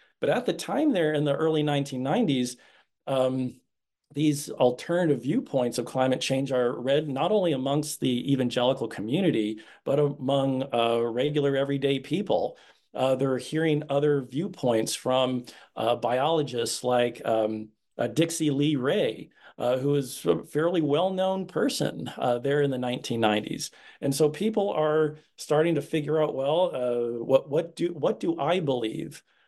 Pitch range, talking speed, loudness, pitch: 125-155 Hz, 150 wpm, -26 LUFS, 140 Hz